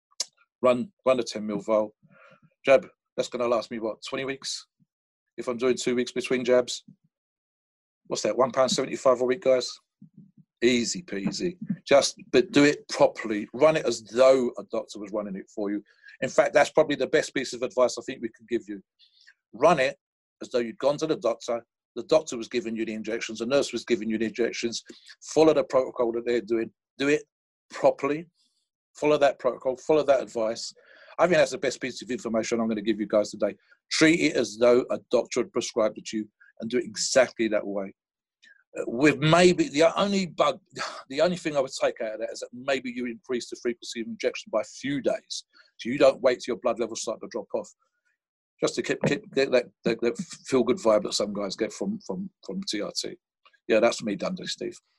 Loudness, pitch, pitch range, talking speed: -26 LUFS, 125 Hz, 115-155 Hz, 215 wpm